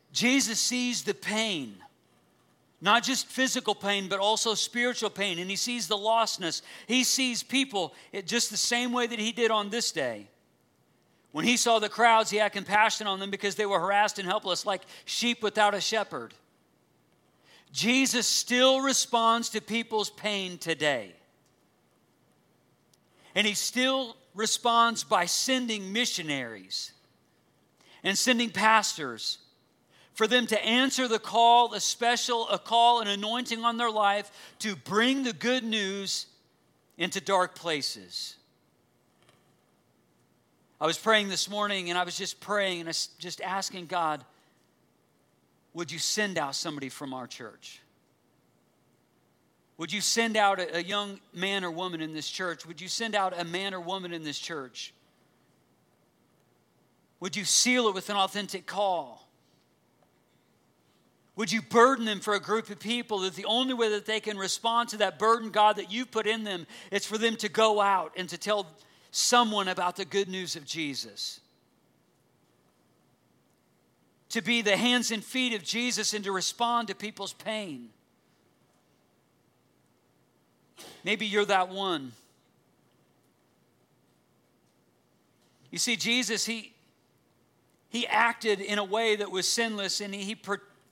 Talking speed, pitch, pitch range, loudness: 145 wpm, 210 Hz, 185-230 Hz, -27 LUFS